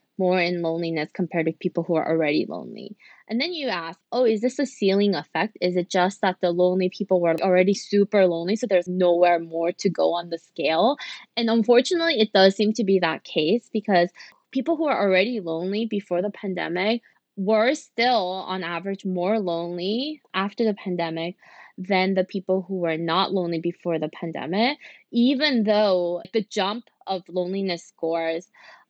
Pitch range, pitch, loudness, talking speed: 175-220 Hz, 190 Hz, -23 LUFS, 175 wpm